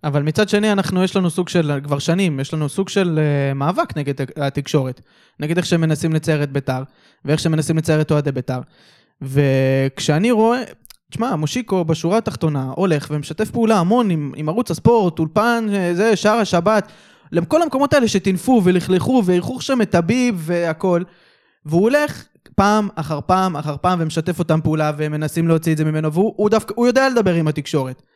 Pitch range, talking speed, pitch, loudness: 150-210 Hz, 175 wpm, 170 Hz, -18 LUFS